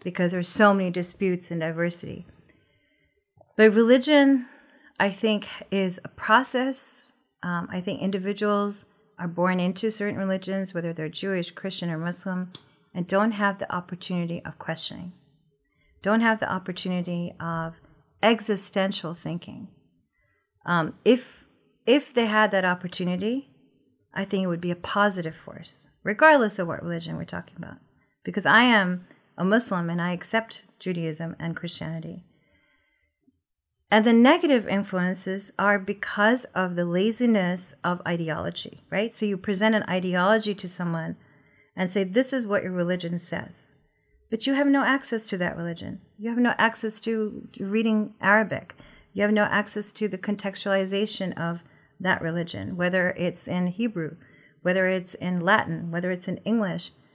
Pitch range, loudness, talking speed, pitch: 175-215 Hz, -25 LUFS, 145 wpm, 190 Hz